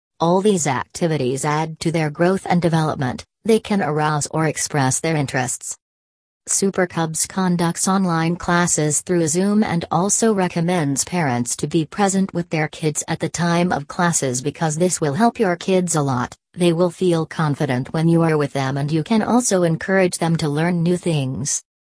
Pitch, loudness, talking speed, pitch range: 165 Hz, -19 LUFS, 180 wpm, 150-180 Hz